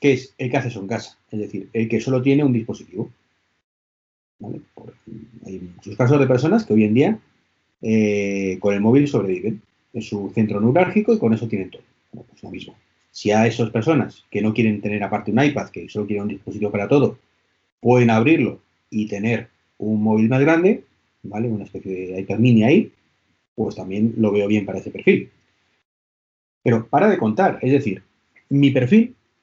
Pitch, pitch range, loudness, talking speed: 105 Hz, 100-120 Hz, -19 LUFS, 190 wpm